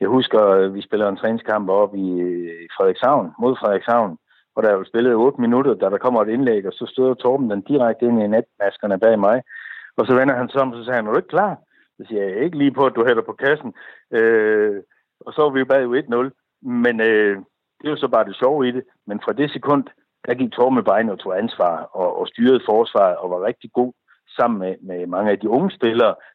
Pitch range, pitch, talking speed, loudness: 100-135 Hz, 120 Hz, 235 wpm, -19 LUFS